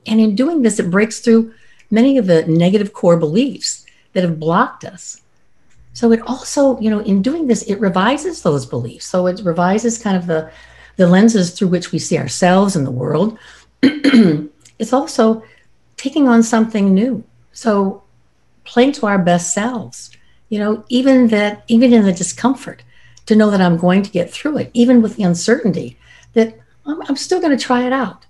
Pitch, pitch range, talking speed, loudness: 215 Hz, 180-245 Hz, 185 wpm, -15 LUFS